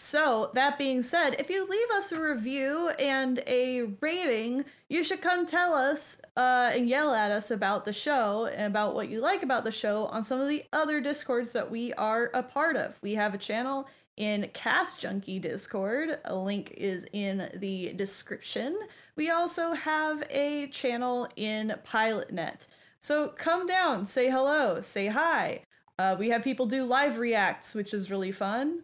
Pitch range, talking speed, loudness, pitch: 215-300 Hz, 175 wpm, -29 LUFS, 255 Hz